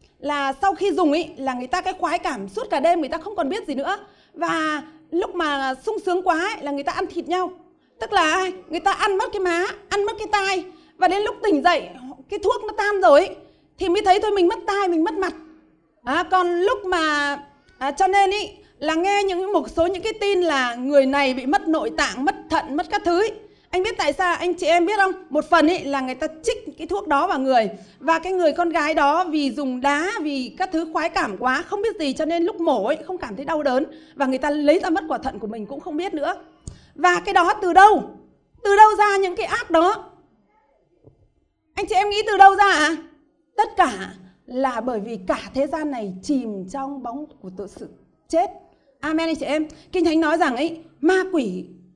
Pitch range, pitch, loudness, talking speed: 290-380 Hz, 335 Hz, -21 LUFS, 240 wpm